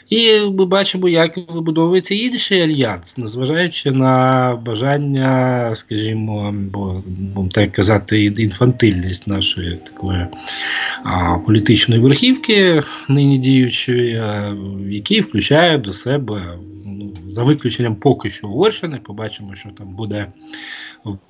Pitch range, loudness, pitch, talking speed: 100-140 Hz, -16 LUFS, 115 Hz, 105 wpm